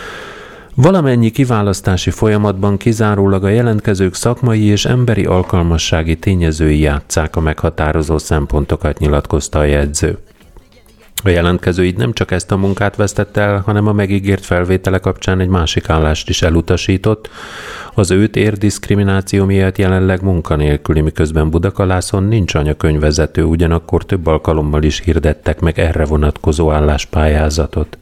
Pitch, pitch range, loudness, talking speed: 90 Hz, 80-100 Hz, -14 LUFS, 125 wpm